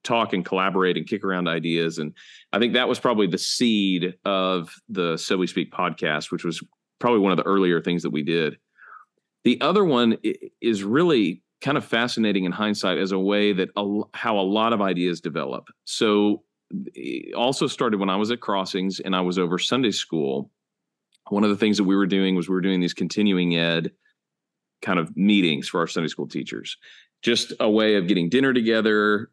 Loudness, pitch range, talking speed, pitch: -23 LUFS, 90-105 Hz, 200 wpm, 95 Hz